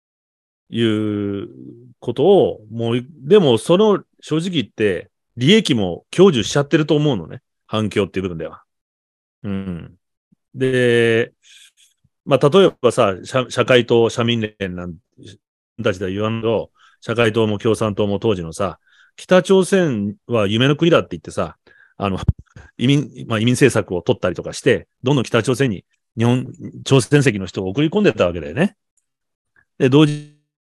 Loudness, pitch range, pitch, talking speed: -18 LUFS, 105-145 Hz, 120 Hz, 275 characters per minute